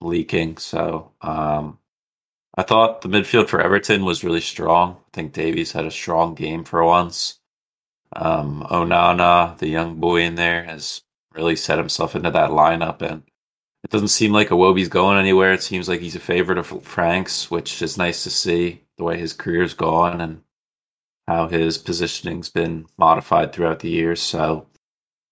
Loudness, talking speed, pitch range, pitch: -19 LUFS, 170 wpm, 80-90 Hz, 85 Hz